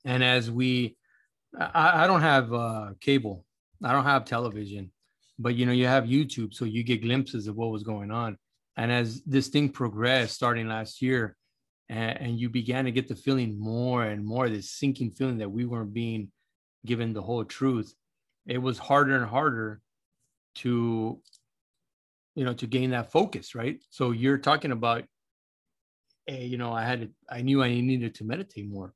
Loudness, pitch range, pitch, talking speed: -27 LUFS, 110-130 Hz, 120 Hz, 180 wpm